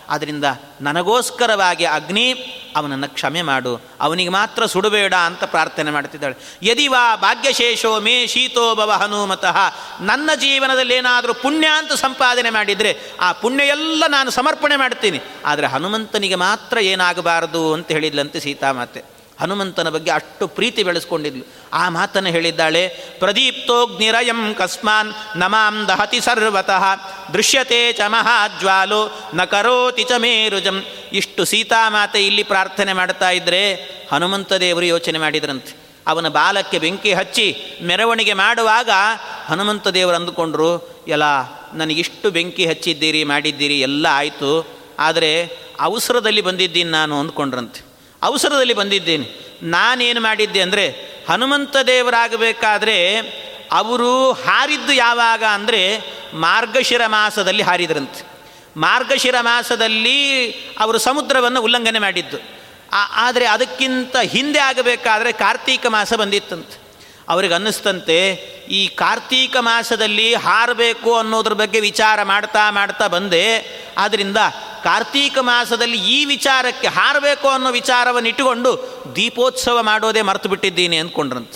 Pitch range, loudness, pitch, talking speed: 175-245 Hz, -16 LUFS, 210 Hz, 100 wpm